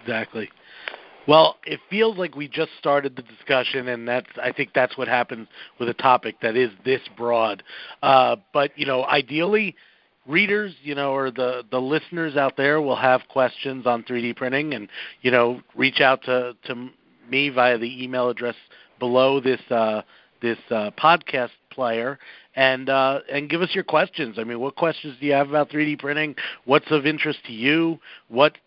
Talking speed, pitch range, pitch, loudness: 190 wpm, 125-150 Hz, 130 Hz, -22 LUFS